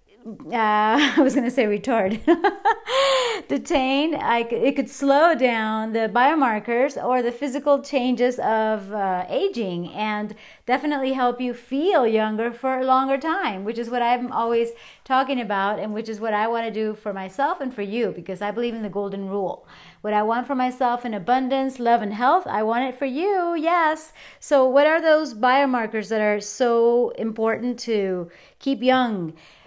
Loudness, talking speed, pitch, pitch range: -22 LUFS, 170 wpm, 240 Hz, 215-275 Hz